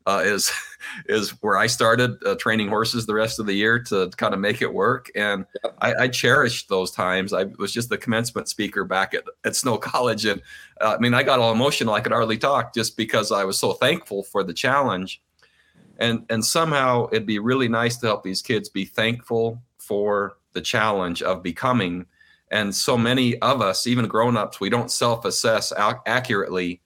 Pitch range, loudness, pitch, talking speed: 100-120 Hz, -22 LUFS, 110 Hz, 200 wpm